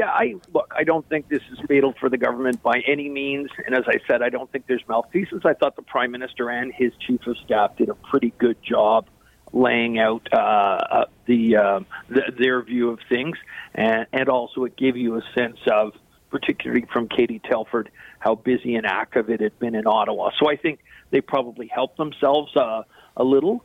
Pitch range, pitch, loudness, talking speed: 115-135 Hz, 125 Hz, -22 LUFS, 205 wpm